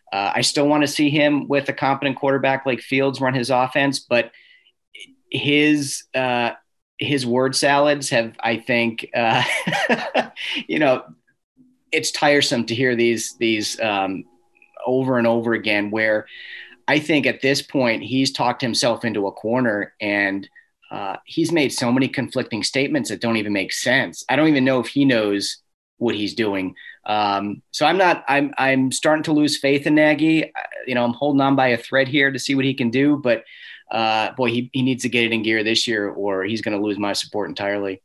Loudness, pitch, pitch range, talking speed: -20 LUFS, 130 Hz, 115-145 Hz, 195 wpm